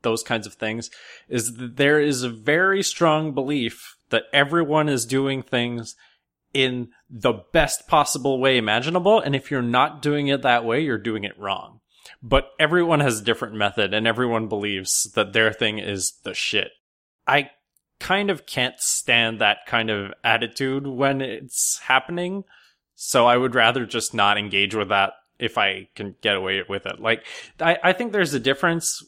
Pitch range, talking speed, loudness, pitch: 115-145 Hz, 175 wpm, -21 LUFS, 125 Hz